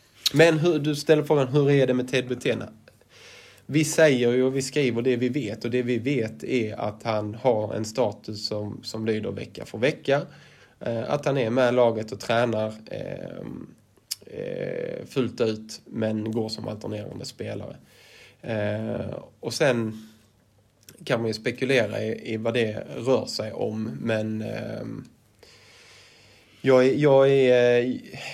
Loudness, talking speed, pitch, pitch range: -25 LUFS, 140 wpm, 120 Hz, 110-135 Hz